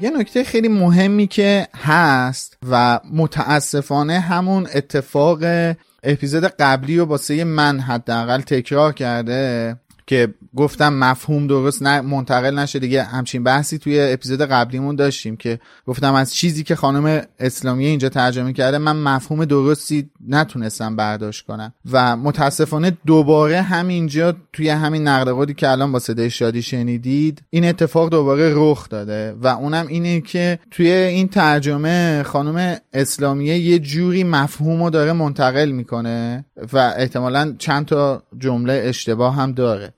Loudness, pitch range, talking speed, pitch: -17 LUFS, 130-160 Hz, 135 wpm, 145 Hz